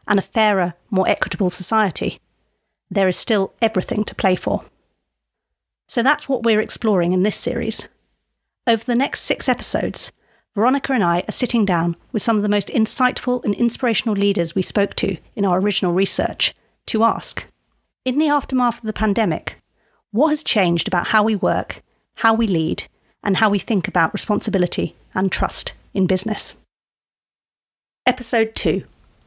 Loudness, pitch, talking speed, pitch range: -19 LUFS, 215 Hz, 160 wpm, 190-230 Hz